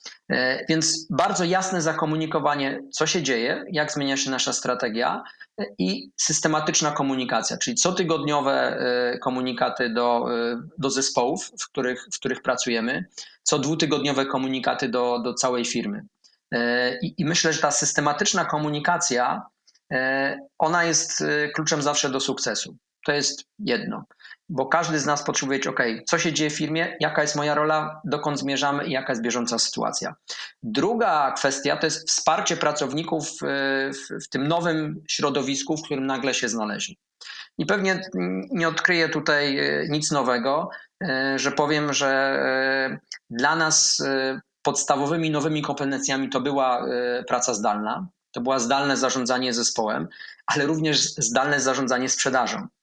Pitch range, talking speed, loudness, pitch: 130-160 Hz, 130 wpm, -23 LUFS, 145 Hz